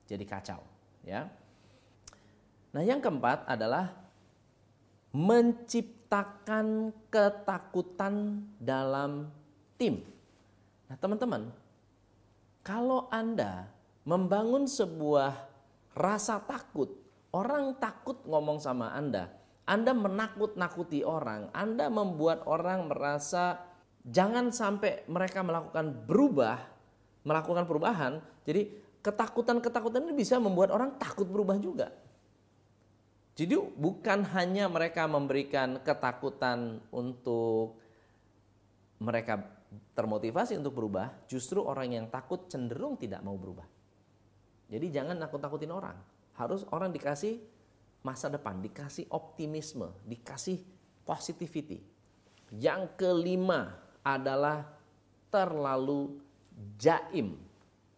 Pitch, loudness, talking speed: 145 Hz, -33 LUFS, 85 wpm